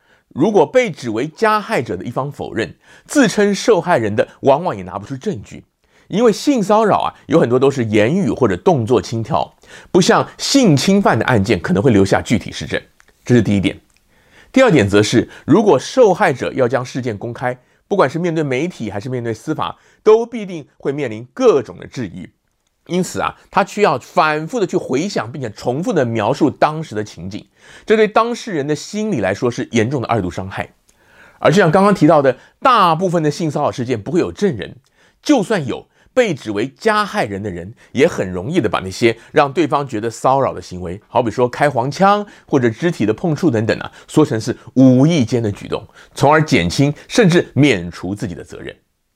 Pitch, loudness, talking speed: 140 Hz, -16 LUFS, 290 characters per minute